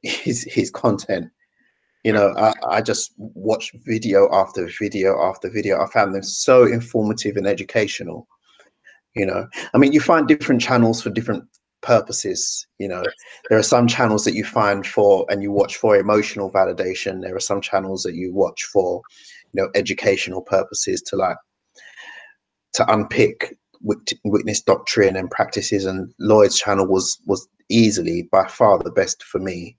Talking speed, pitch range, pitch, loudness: 160 wpm, 95-140 Hz, 105 Hz, -19 LUFS